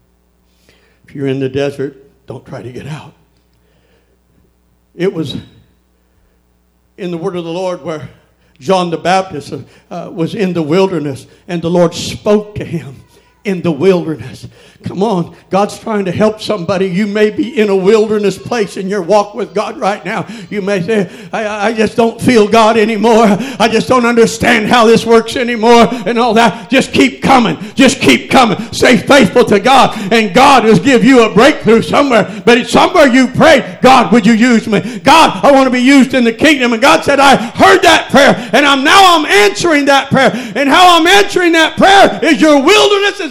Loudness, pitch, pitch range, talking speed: -9 LUFS, 215 Hz, 180-245 Hz, 190 wpm